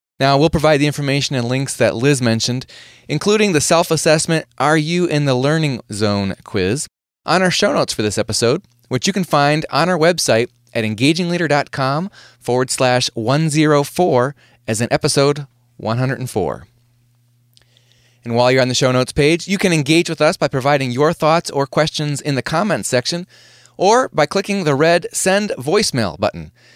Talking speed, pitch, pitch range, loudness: 170 wpm, 145 Hz, 120-160 Hz, -16 LUFS